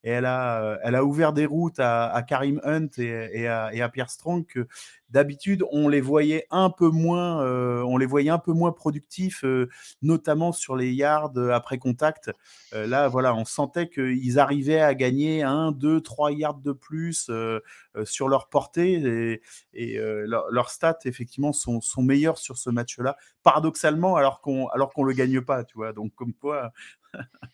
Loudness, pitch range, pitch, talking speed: -24 LUFS, 125-155 Hz, 135 Hz, 190 wpm